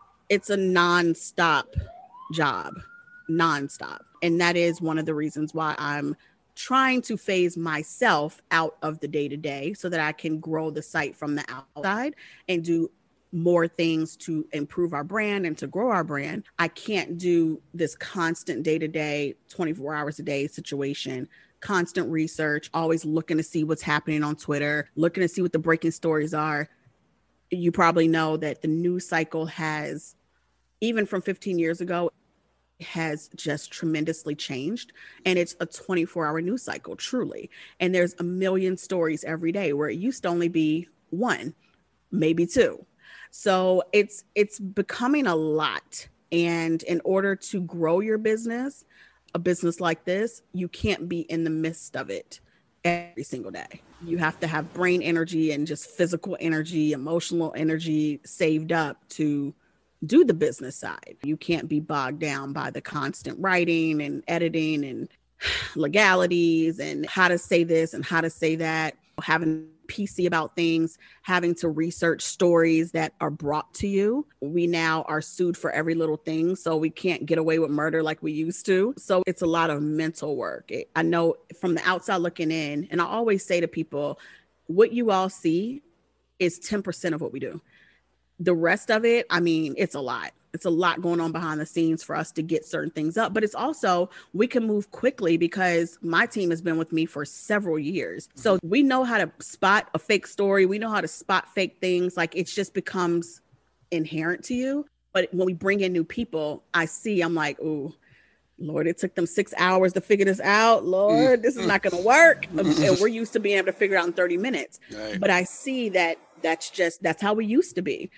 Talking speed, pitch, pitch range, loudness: 190 wpm, 170 Hz, 160-185 Hz, -25 LUFS